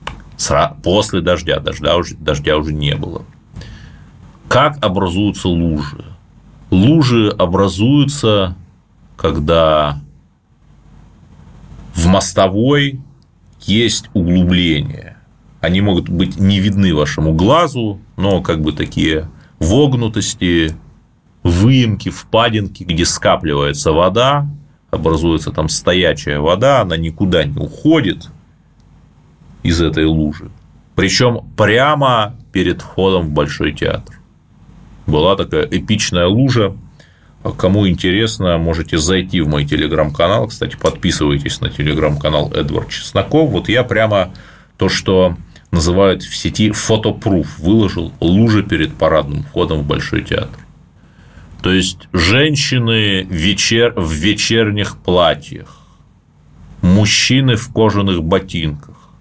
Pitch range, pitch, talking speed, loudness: 85-110 Hz, 95 Hz, 100 wpm, -14 LUFS